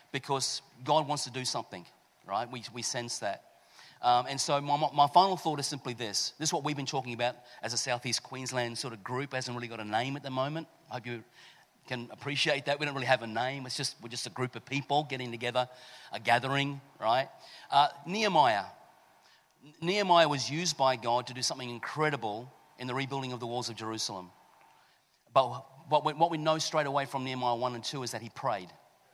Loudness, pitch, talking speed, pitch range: -31 LUFS, 130 Hz, 215 wpm, 120-145 Hz